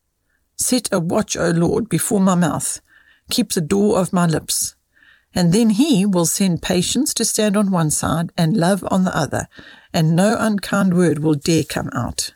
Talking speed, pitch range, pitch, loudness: 185 wpm, 170-210 Hz, 185 Hz, -18 LUFS